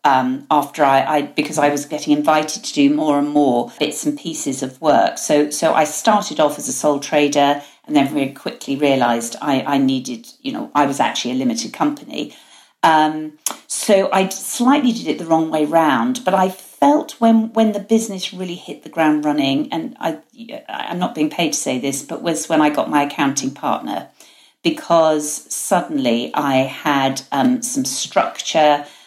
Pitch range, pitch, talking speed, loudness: 145-205 Hz, 155 Hz, 185 wpm, -18 LUFS